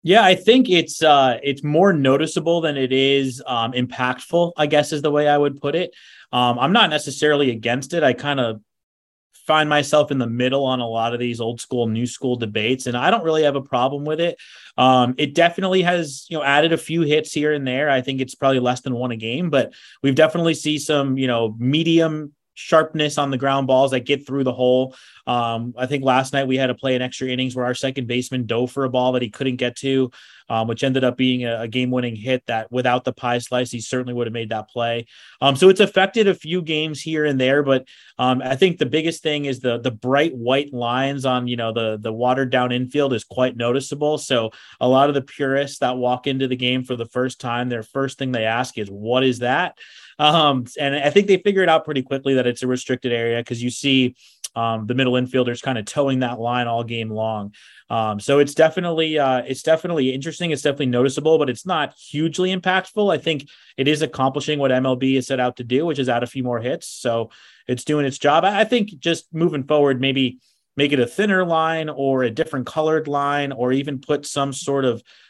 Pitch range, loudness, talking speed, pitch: 125-150 Hz, -20 LUFS, 230 wpm, 130 Hz